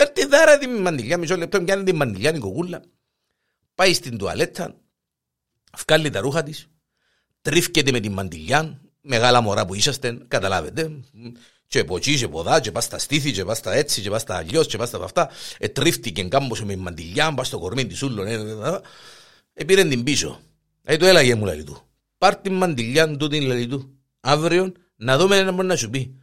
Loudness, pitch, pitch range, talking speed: -20 LUFS, 140 Hz, 115-165 Hz, 190 wpm